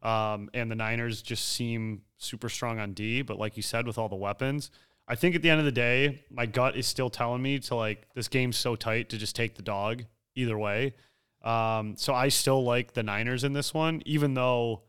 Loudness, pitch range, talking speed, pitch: -29 LUFS, 110-130 Hz, 230 wpm, 120 Hz